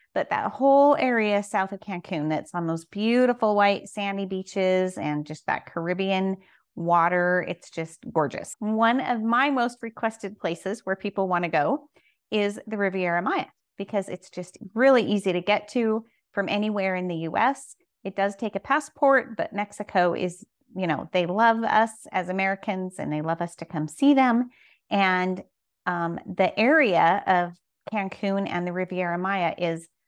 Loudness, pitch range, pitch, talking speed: -25 LUFS, 180-220 Hz, 195 Hz, 170 wpm